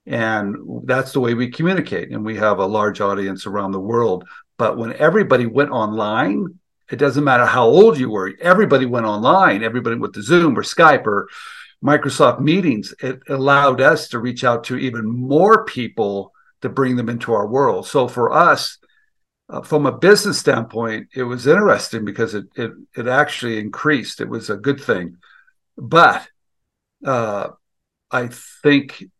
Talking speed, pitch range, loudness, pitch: 165 wpm, 110-145 Hz, -17 LUFS, 125 Hz